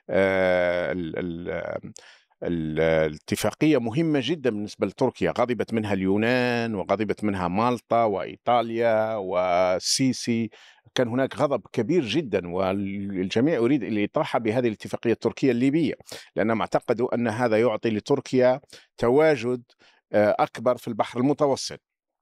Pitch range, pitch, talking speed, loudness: 100-125 Hz, 115 Hz, 105 wpm, -24 LUFS